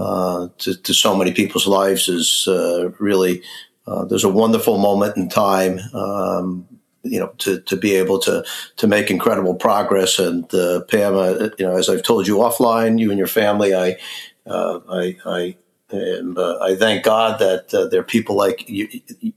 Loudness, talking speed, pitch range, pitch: -18 LUFS, 190 wpm, 90-110 Hz, 95 Hz